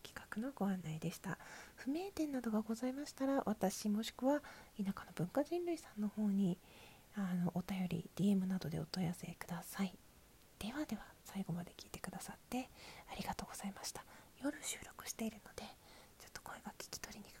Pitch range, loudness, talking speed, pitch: 180-255 Hz, -43 LUFS, 365 characters per minute, 200 Hz